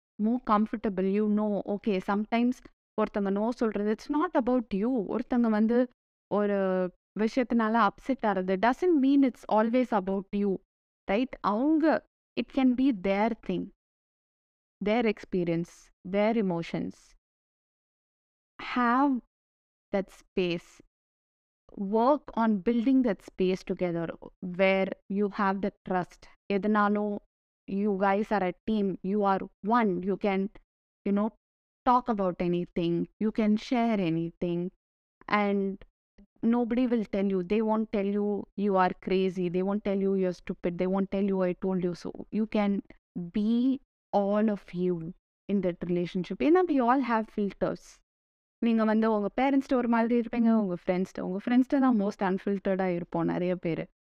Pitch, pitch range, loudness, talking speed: 205 Hz, 190-230 Hz, -28 LUFS, 130 wpm